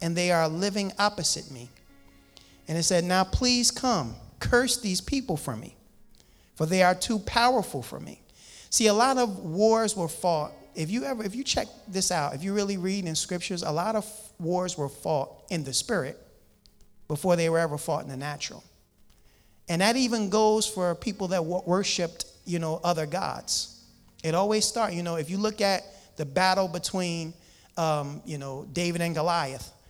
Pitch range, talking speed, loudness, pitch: 155-205 Hz, 185 wpm, -27 LUFS, 175 Hz